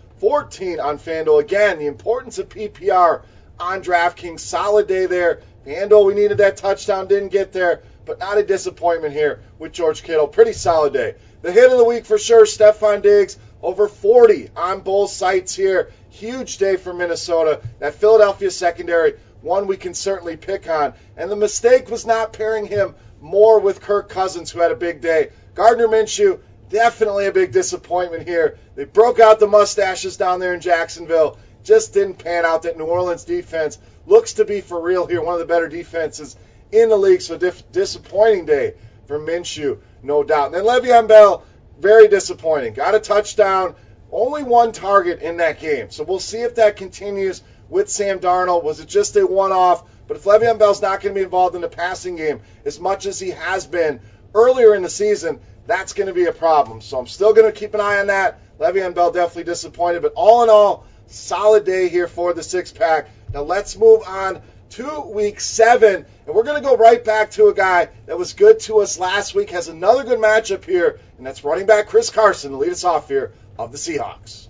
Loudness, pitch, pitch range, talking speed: -16 LUFS, 200 Hz, 175-235 Hz, 195 wpm